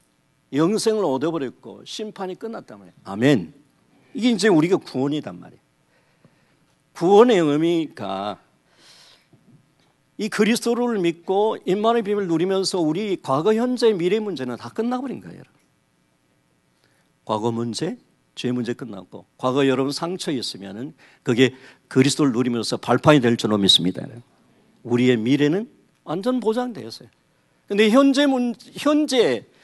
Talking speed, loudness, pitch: 295 characters per minute, -21 LUFS, 165 Hz